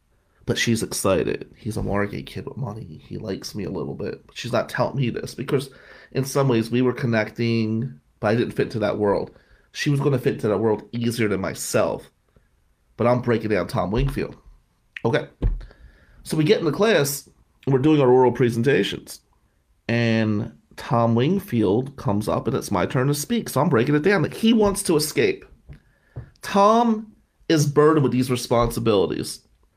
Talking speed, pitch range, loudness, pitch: 185 wpm, 110-145 Hz, -22 LUFS, 120 Hz